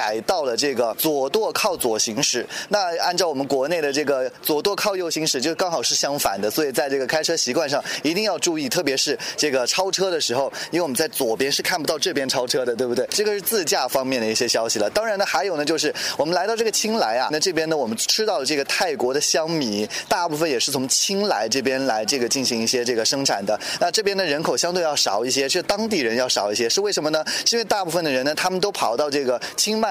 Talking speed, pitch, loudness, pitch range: 380 characters per minute, 155 Hz, -21 LUFS, 135-205 Hz